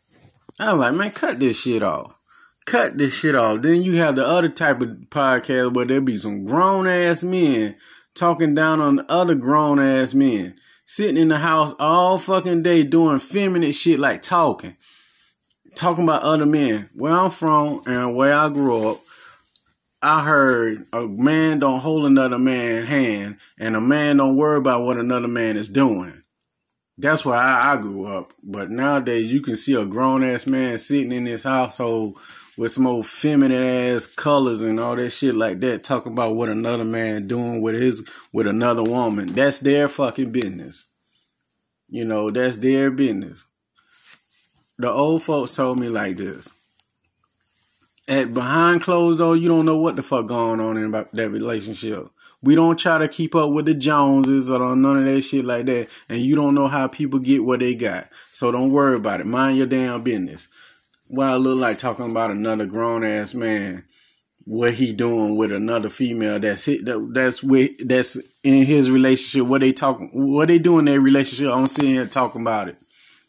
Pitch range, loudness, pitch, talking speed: 115-145 Hz, -19 LUFS, 130 Hz, 185 wpm